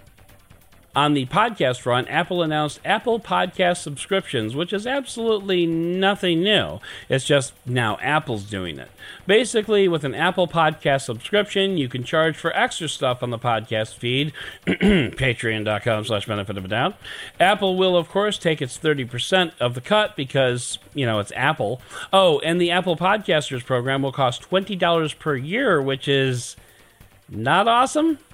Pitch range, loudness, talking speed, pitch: 125-190 Hz, -21 LUFS, 150 wpm, 150 Hz